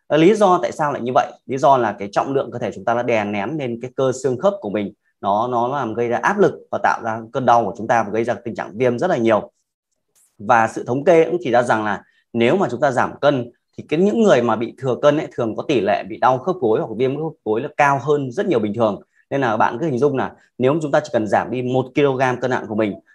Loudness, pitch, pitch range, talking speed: -19 LUFS, 125 Hz, 115-145 Hz, 295 wpm